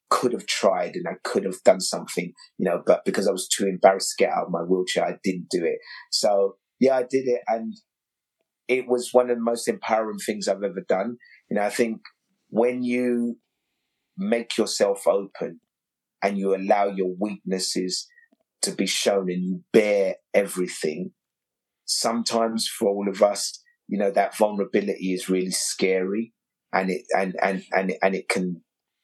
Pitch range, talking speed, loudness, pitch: 95-125 Hz, 175 wpm, -24 LUFS, 105 Hz